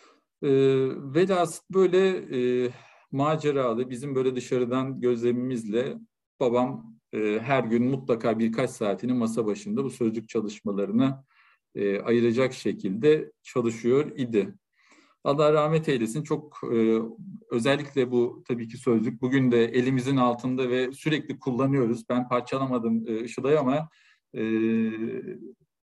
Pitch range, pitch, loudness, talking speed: 115-140 Hz, 125 Hz, -26 LUFS, 115 wpm